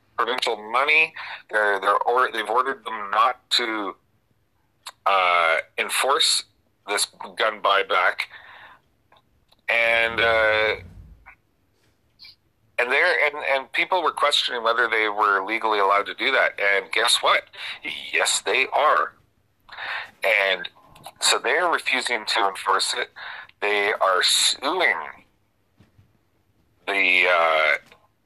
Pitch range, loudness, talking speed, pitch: 95-110 Hz, -21 LUFS, 105 wpm, 105 Hz